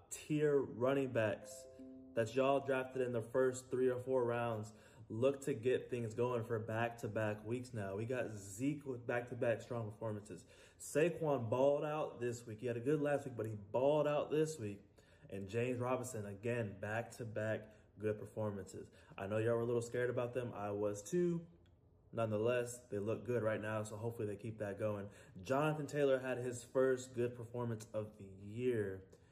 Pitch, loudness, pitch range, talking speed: 120 Hz, -39 LUFS, 110-130 Hz, 190 wpm